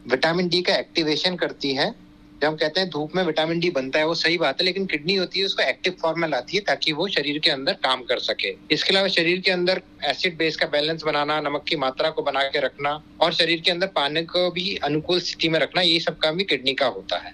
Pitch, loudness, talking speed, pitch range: 165 Hz, -22 LUFS, 255 wpm, 150-180 Hz